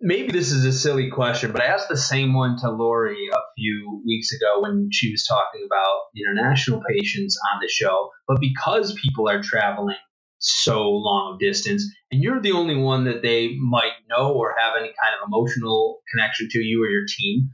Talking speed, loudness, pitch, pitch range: 195 wpm, -21 LUFS, 130 Hz, 115-185 Hz